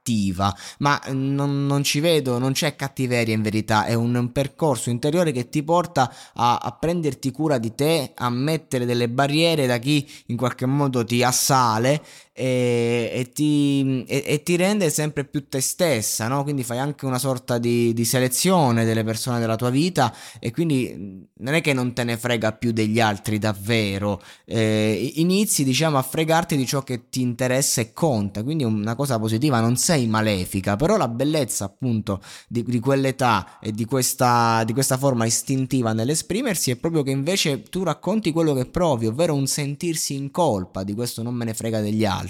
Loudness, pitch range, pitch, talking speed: -22 LUFS, 115-145 Hz, 130 Hz, 185 wpm